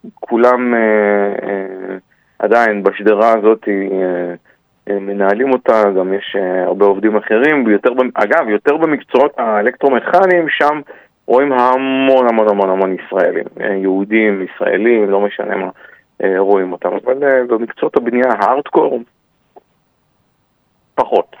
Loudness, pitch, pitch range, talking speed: -14 LUFS, 105 Hz, 100-125 Hz, 115 wpm